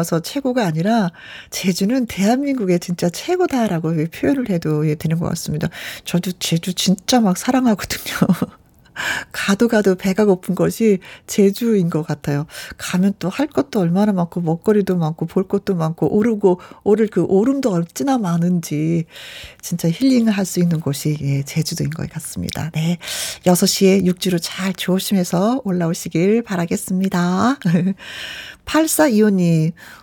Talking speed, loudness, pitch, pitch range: 285 characters per minute, -18 LUFS, 185 Hz, 170-215 Hz